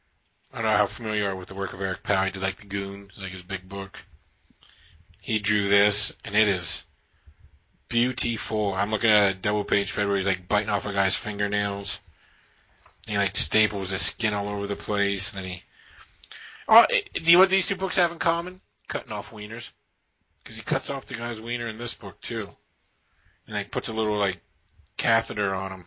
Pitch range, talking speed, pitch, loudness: 95-110 Hz, 215 wpm, 100 Hz, -25 LUFS